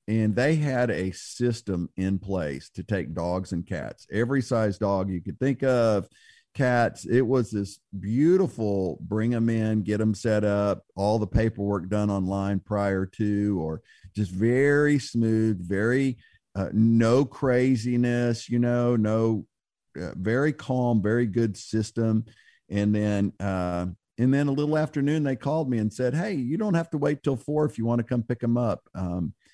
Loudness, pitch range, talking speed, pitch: -26 LUFS, 100-125 Hz, 175 wpm, 110 Hz